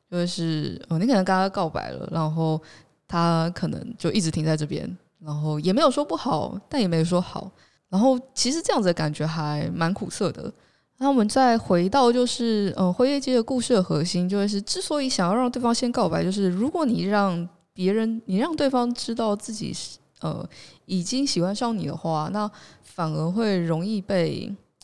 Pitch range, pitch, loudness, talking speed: 165-240 Hz, 195 Hz, -24 LUFS, 285 characters per minute